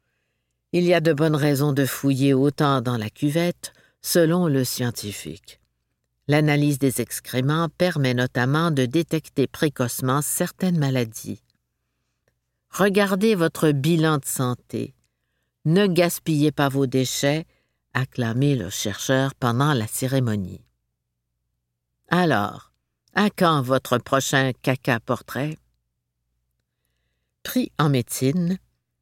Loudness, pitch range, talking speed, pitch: -22 LUFS, 110-155 Hz, 105 wpm, 135 Hz